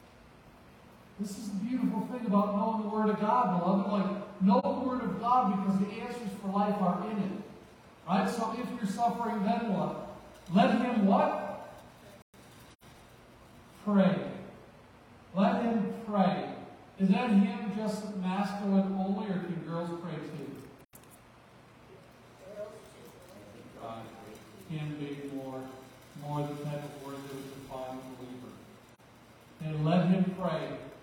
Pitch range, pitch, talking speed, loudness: 145-210 Hz, 190 Hz, 130 wpm, -31 LUFS